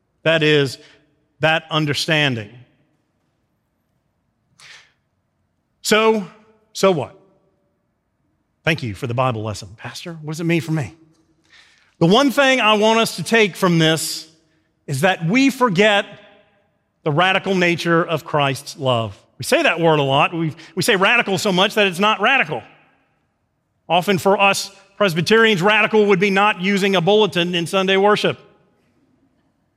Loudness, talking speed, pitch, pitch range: -17 LUFS, 140 wpm, 175 Hz, 155-205 Hz